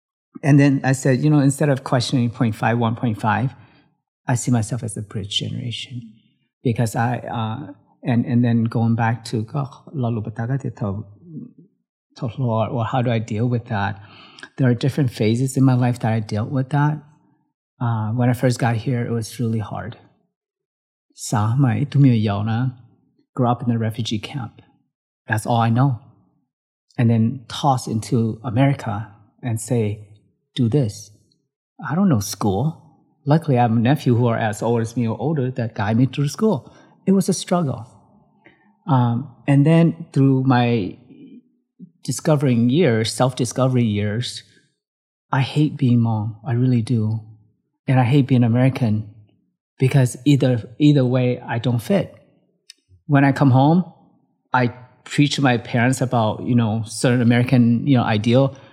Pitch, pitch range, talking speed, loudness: 125 Hz, 115-140 Hz, 150 wpm, -20 LUFS